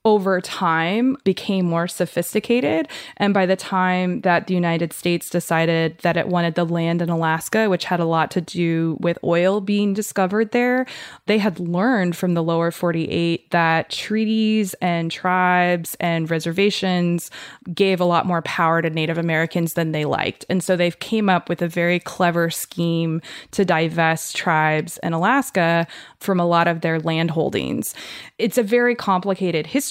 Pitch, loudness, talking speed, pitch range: 175 Hz, -20 LUFS, 165 wpm, 165-195 Hz